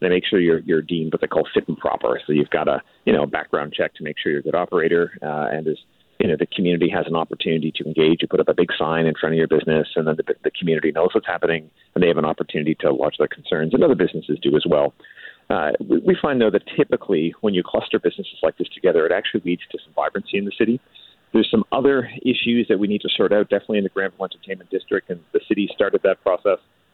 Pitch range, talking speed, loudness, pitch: 85-140 Hz, 260 wpm, -20 LUFS, 100 Hz